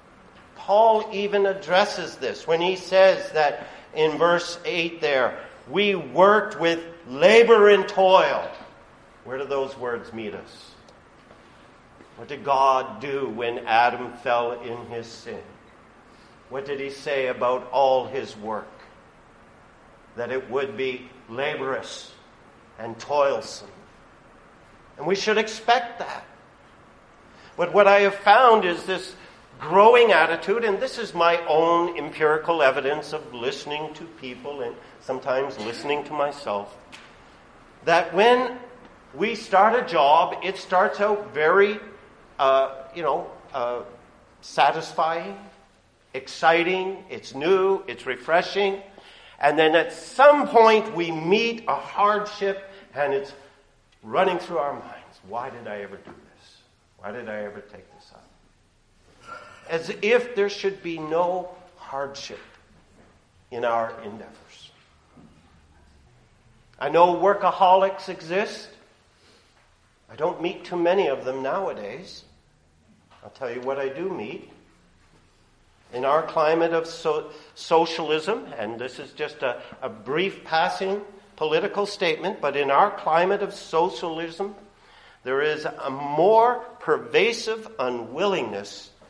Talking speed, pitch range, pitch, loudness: 125 wpm, 130-195 Hz, 165 Hz, -22 LUFS